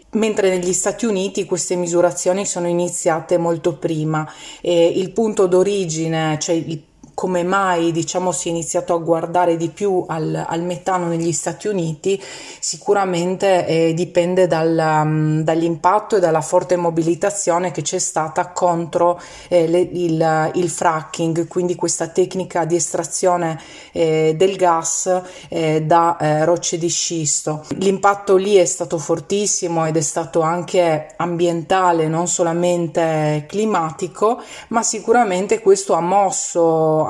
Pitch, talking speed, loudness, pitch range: 175 Hz, 135 wpm, -18 LUFS, 165-185 Hz